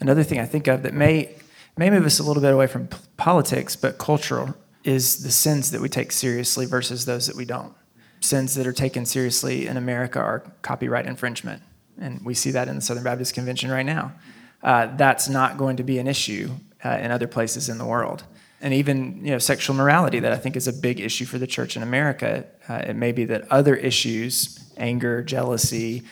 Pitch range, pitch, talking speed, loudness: 125-135 Hz, 130 Hz, 215 wpm, -22 LUFS